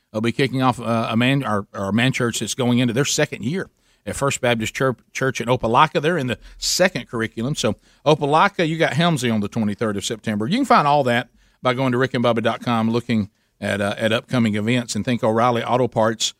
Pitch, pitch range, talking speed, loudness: 120 Hz, 110-135 Hz, 210 wpm, -20 LUFS